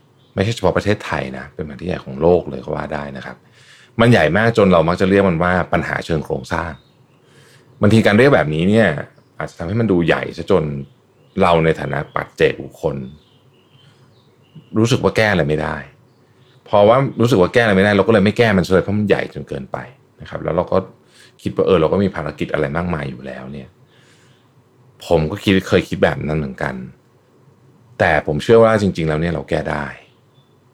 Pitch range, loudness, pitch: 75-115 Hz, -16 LUFS, 95 Hz